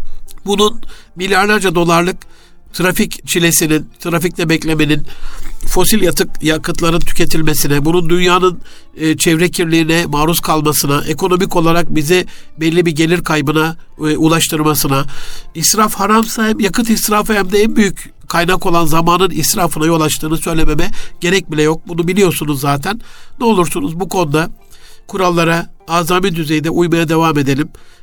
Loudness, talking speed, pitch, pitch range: -13 LUFS, 120 wpm, 170 Hz, 155-185 Hz